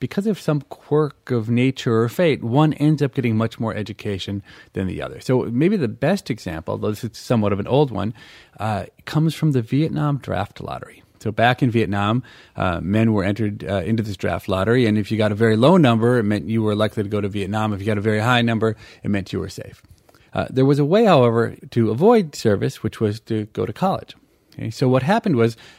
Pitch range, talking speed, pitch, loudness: 105-135 Hz, 235 wpm, 115 Hz, -20 LUFS